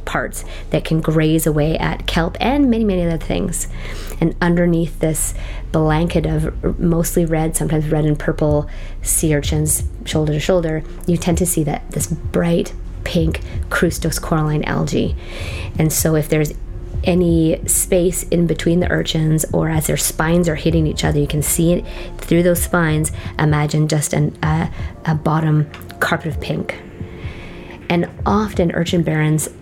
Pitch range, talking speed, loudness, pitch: 145-170 Hz, 155 wpm, -18 LUFS, 155 Hz